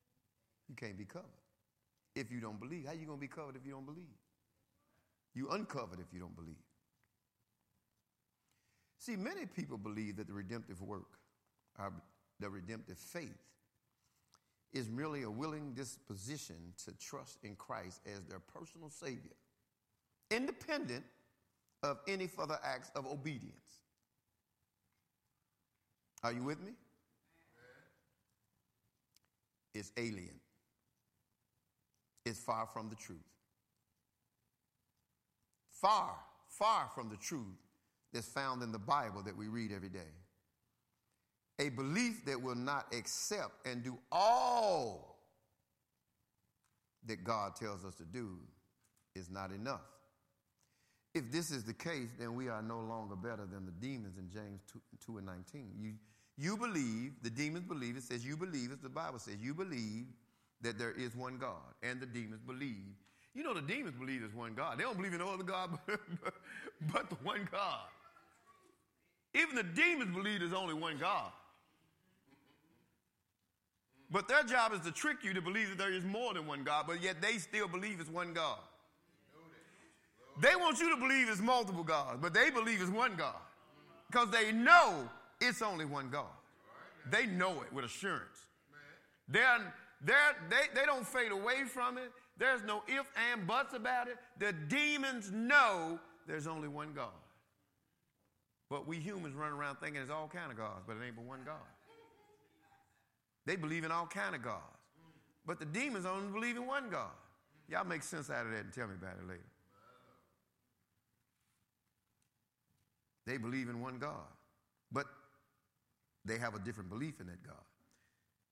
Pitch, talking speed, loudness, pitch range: 130 Hz, 155 wpm, -38 LUFS, 110-180 Hz